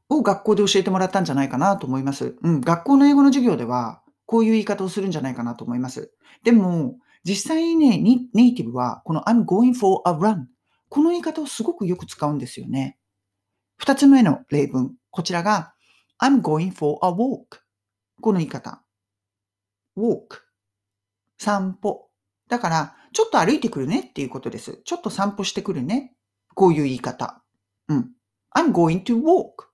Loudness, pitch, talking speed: -21 LUFS, 185 Hz, 390 characters per minute